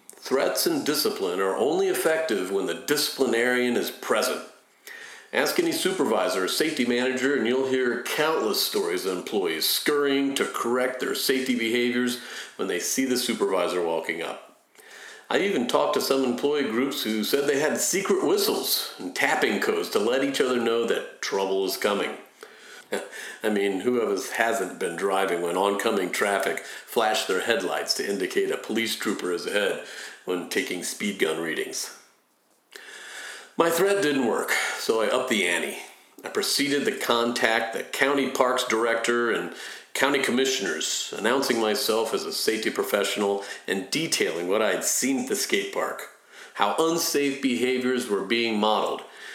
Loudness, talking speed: -25 LUFS, 155 wpm